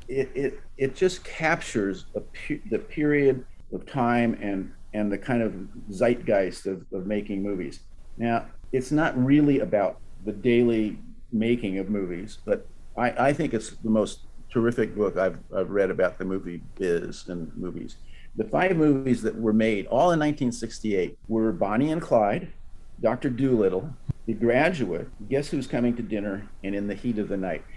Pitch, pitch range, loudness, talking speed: 115 Hz, 100-135 Hz, -26 LUFS, 170 wpm